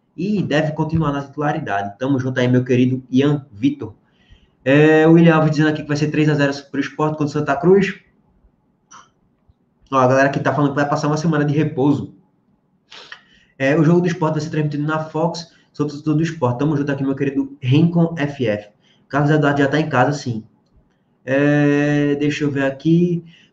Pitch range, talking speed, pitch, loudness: 135-155 Hz, 190 wpm, 145 Hz, -18 LUFS